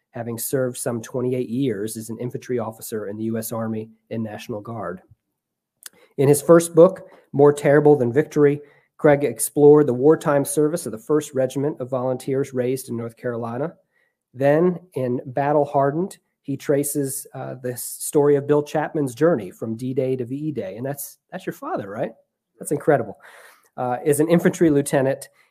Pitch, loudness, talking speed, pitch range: 140 Hz, -21 LUFS, 165 wpm, 125-150 Hz